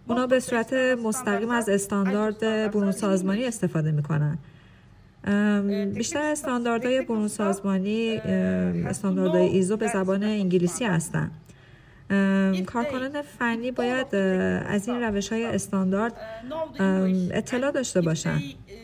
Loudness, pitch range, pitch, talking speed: -25 LUFS, 185-235 Hz, 205 Hz, 100 wpm